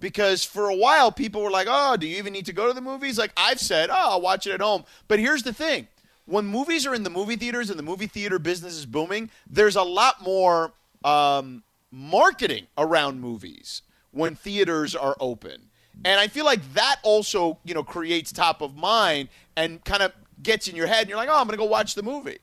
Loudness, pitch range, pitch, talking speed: -23 LUFS, 165-225 Hz, 195 Hz, 225 wpm